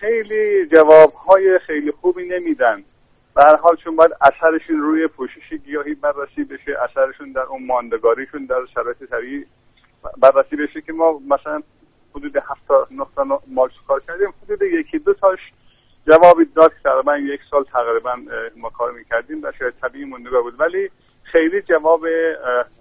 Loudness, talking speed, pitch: -16 LUFS, 145 wpm, 160 Hz